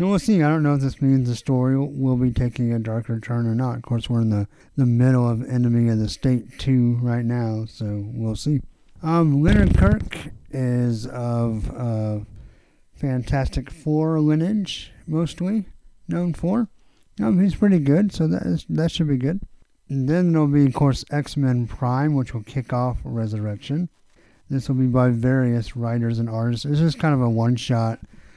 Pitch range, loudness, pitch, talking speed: 115-145 Hz, -22 LUFS, 125 Hz, 185 wpm